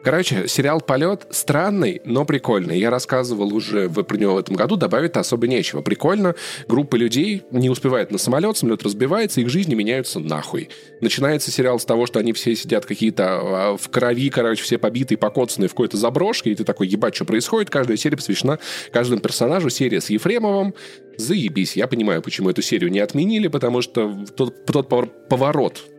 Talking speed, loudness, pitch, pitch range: 175 wpm, -20 LUFS, 130 Hz, 115-155 Hz